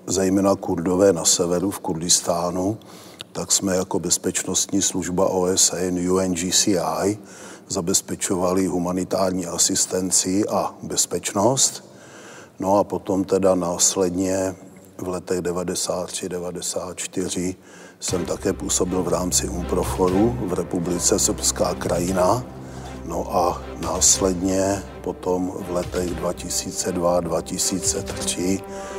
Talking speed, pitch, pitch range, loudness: 95 wpm, 90 Hz, 90-95 Hz, -21 LUFS